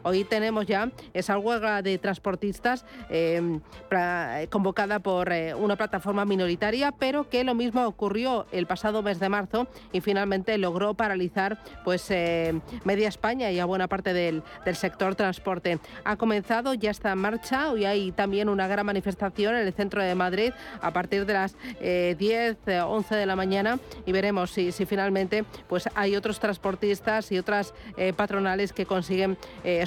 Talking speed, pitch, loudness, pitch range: 170 wpm, 200 Hz, -27 LUFS, 185-215 Hz